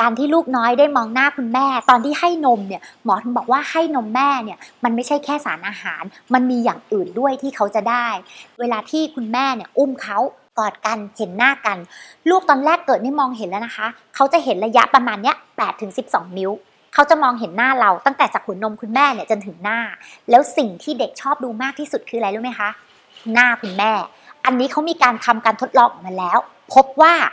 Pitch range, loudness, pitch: 220-275 Hz, -18 LUFS, 245 Hz